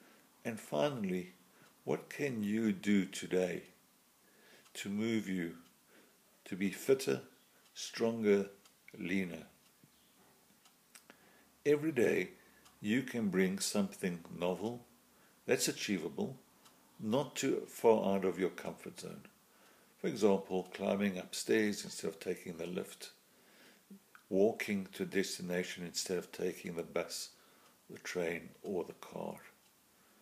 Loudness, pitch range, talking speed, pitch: -37 LUFS, 90-115 Hz, 105 wpm, 100 Hz